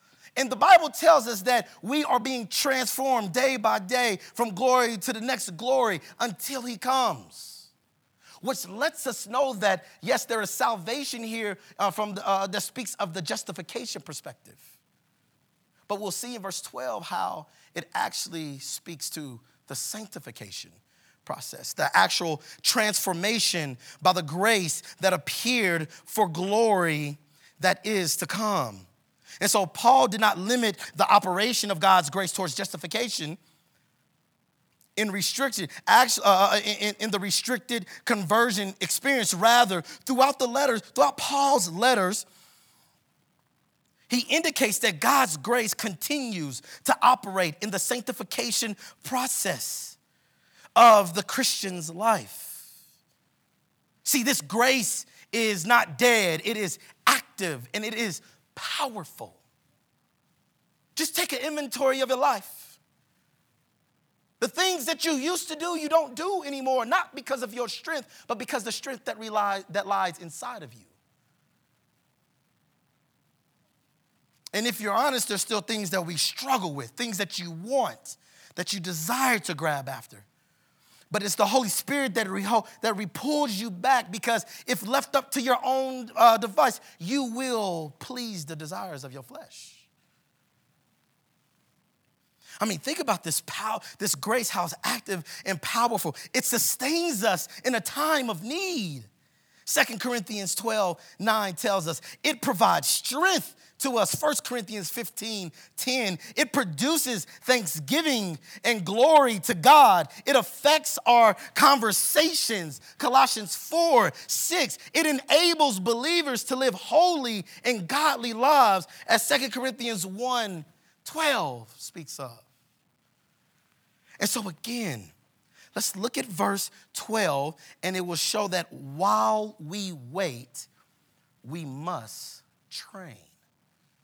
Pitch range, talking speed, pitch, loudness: 180-255 Hz, 130 wpm, 215 Hz, -25 LUFS